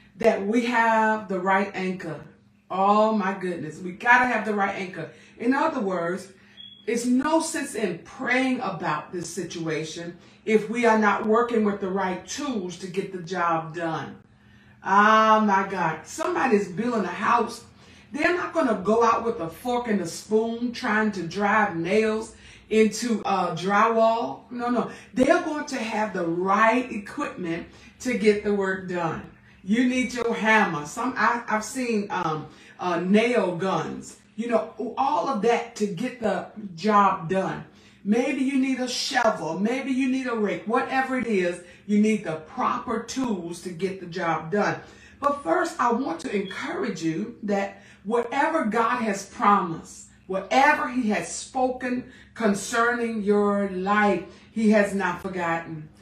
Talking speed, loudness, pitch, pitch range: 155 wpm, -24 LUFS, 215 Hz, 185-235 Hz